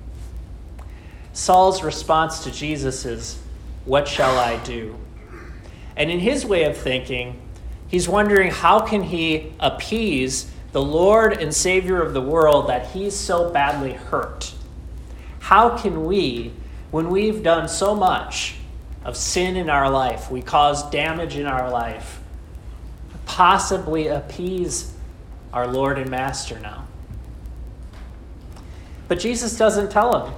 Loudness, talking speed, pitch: -20 LUFS, 125 wpm, 135 Hz